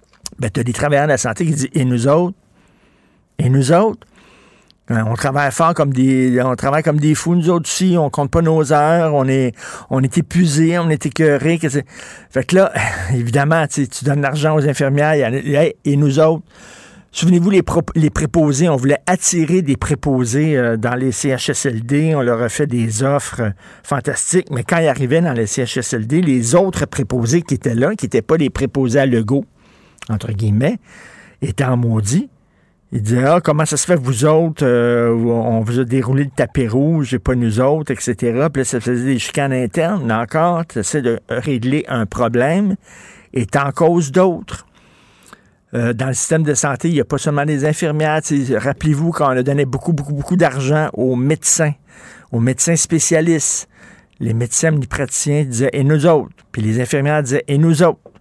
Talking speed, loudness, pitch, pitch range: 190 wpm, -16 LUFS, 145 Hz, 125-160 Hz